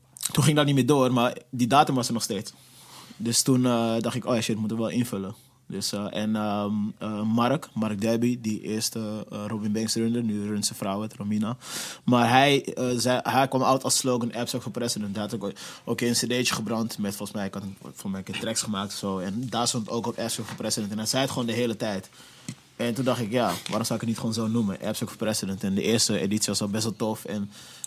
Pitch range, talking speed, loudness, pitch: 105-120 Hz, 250 wpm, -26 LUFS, 115 Hz